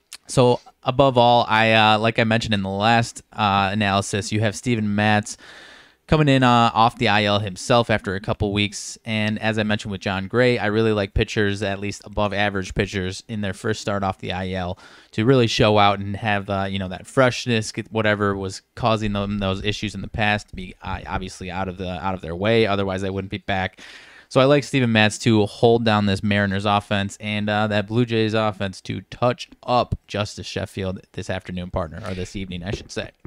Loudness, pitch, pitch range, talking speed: -21 LUFS, 105 Hz, 95-110 Hz, 215 wpm